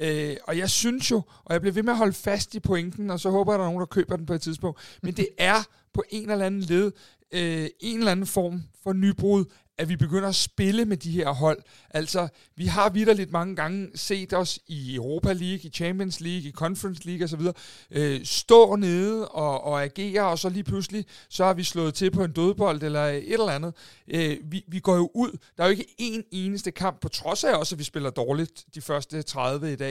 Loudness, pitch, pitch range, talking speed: -26 LUFS, 180 Hz, 155-195 Hz, 230 wpm